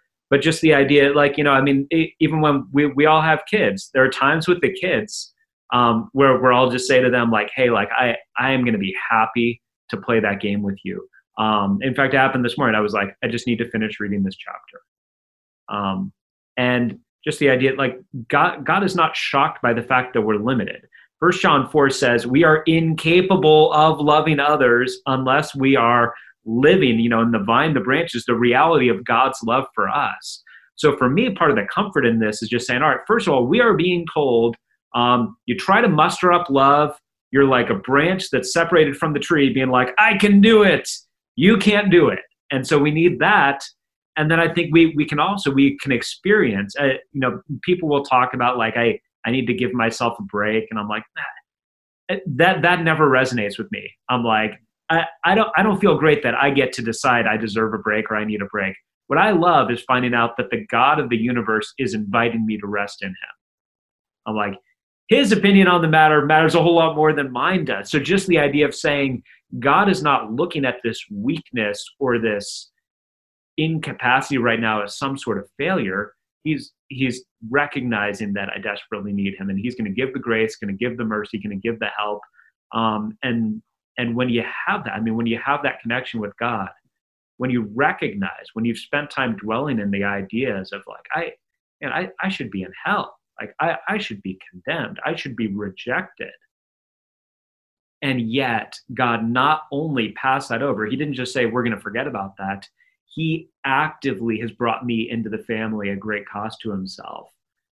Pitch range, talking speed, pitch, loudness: 115-155 Hz, 210 wpm, 130 Hz, -19 LUFS